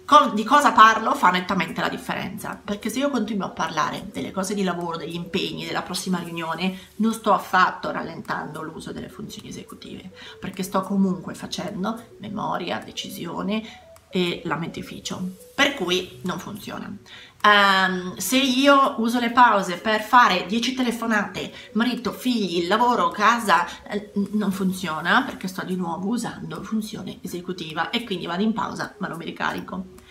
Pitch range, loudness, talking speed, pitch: 185-225 Hz, -22 LUFS, 150 wpm, 200 Hz